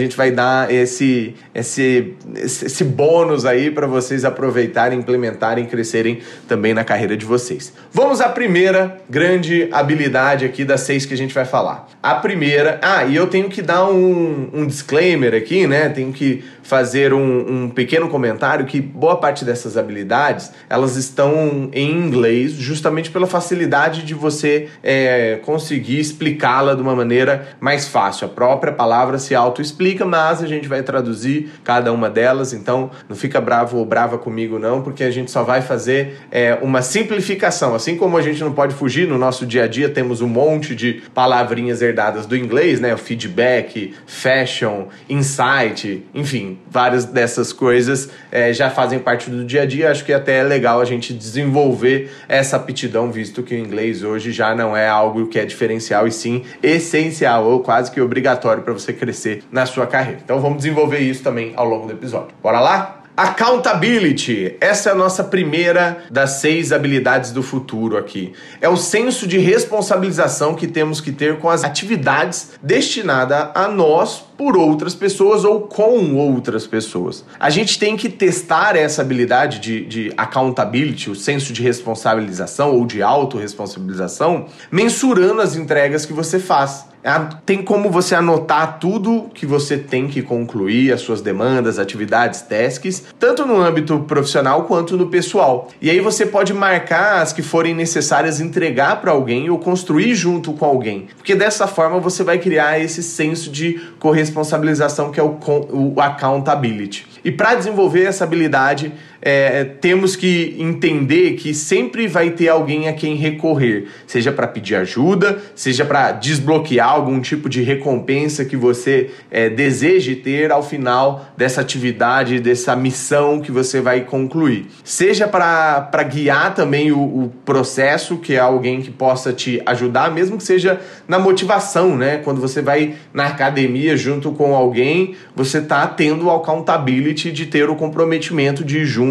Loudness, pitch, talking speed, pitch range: -16 LUFS, 140 Hz, 165 wpm, 125-165 Hz